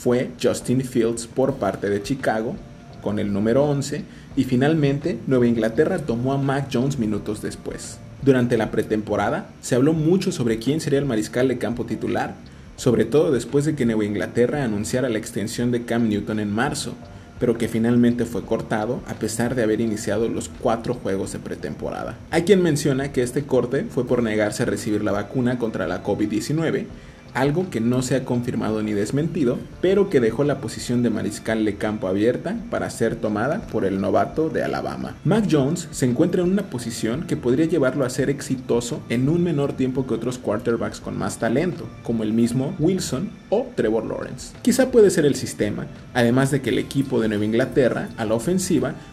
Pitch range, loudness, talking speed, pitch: 110-140 Hz, -22 LUFS, 185 wpm, 120 Hz